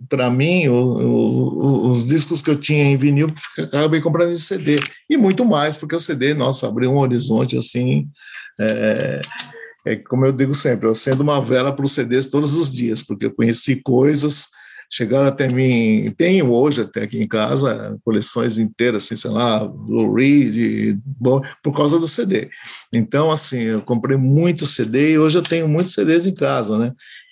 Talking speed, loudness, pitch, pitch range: 185 wpm, -17 LUFS, 135 Hz, 120-150 Hz